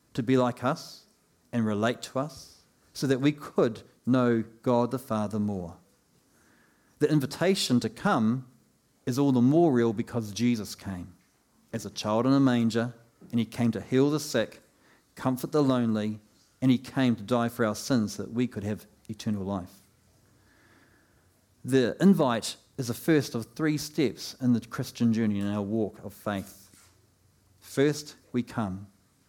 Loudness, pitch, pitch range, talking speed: -28 LUFS, 115 Hz, 105-130 Hz, 165 wpm